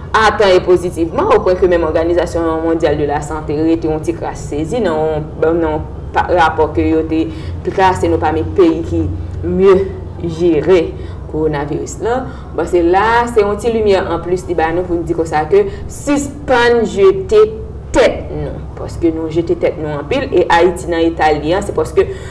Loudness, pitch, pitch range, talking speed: -14 LUFS, 165 Hz, 155-190 Hz, 190 wpm